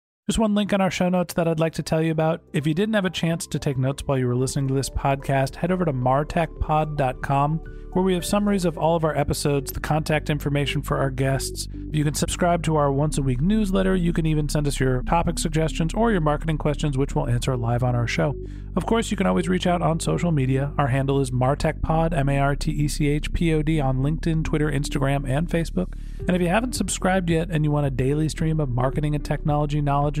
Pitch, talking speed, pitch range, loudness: 150 Hz, 245 wpm, 140-170 Hz, -23 LUFS